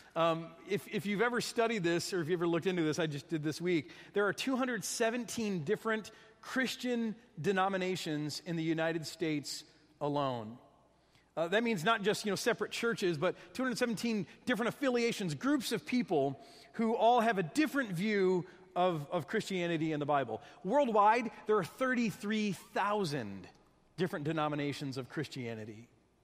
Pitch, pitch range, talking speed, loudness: 190 Hz, 160-225 Hz, 150 wpm, -34 LUFS